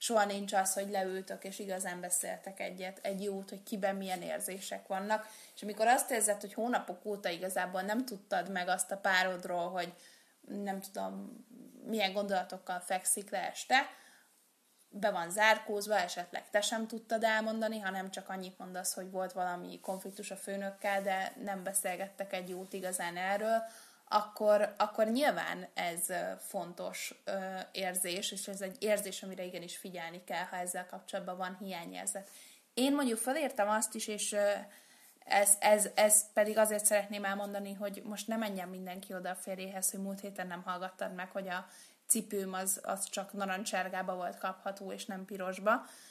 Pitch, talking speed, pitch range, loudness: 195 Hz, 155 wpm, 185-210 Hz, -35 LUFS